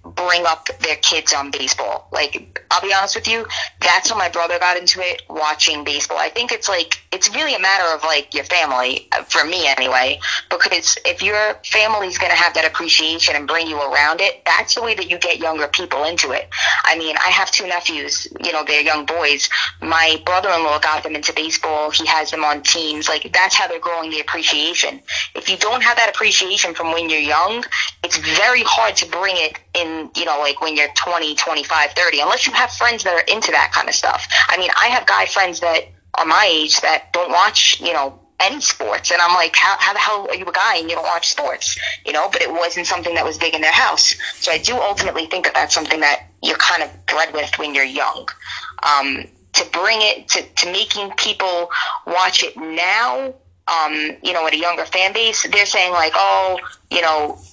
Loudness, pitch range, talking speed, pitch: -16 LUFS, 150-185 Hz, 225 wpm, 165 Hz